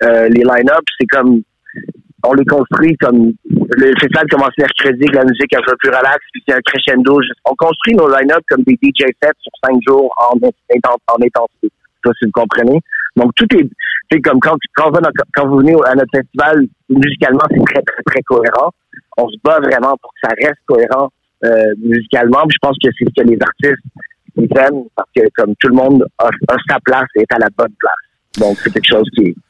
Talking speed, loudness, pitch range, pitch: 225 wpm, -11 LUFS, 120-145 Hz, 135 Hz